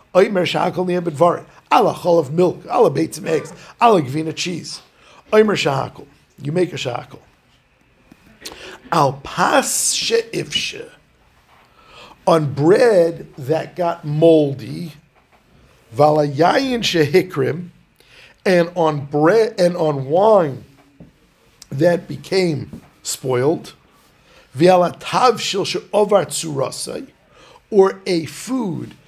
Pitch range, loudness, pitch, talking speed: 150-185 Hz, -17 LUFS, 170 Hz, 100 wpm